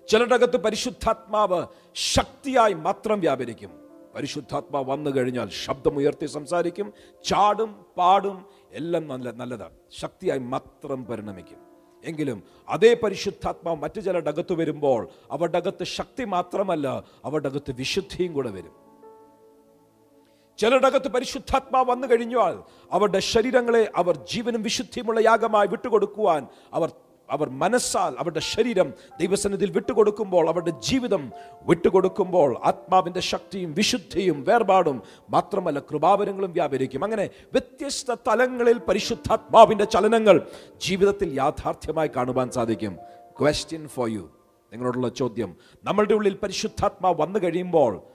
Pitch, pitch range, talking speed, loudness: 185 Hz, 145-220 Hz, 95 wpm, -23 LUFS